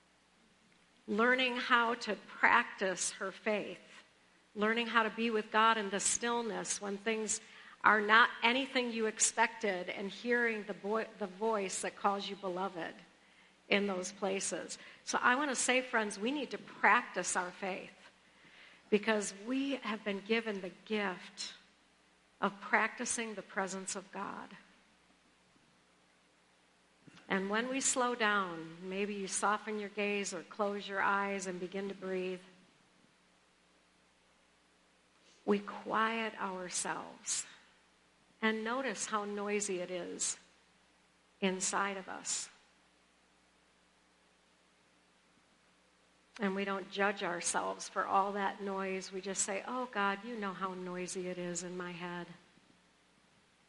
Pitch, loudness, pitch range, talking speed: 195 Hz, -35 LUFS, 175-215 Hz, 125 wpm